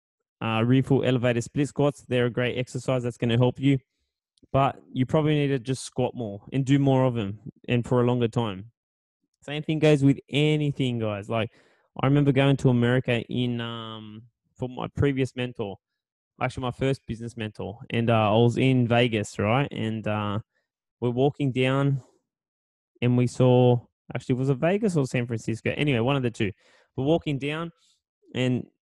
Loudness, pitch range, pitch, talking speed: -25 LUFS, 115-140 Hz, 125 Hz, 180 wpm